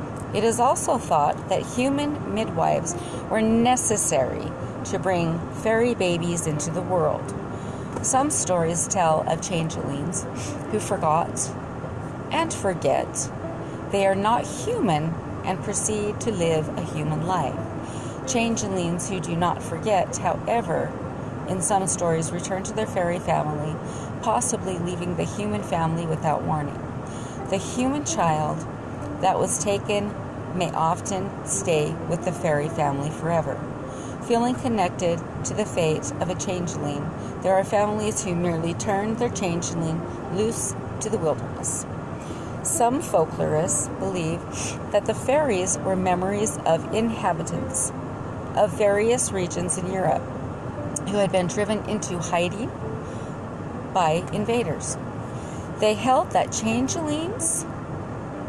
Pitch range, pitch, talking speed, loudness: 165-215 Hz, 185 Hz, 120 wpm, -25 LUFS